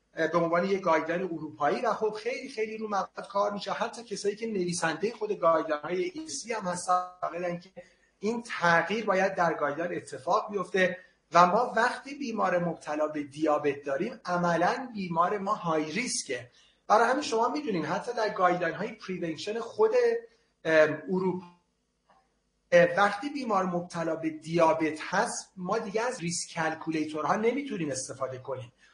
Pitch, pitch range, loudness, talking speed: 180 Hz, 165-220 Hz, -29 LUFS, 140 wpm